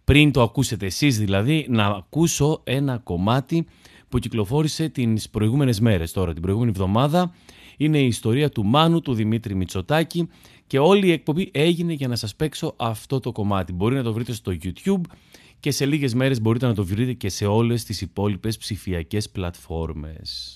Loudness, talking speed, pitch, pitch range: -22 LUFS, 170 wpm, 120 Hz, 100-145 Hz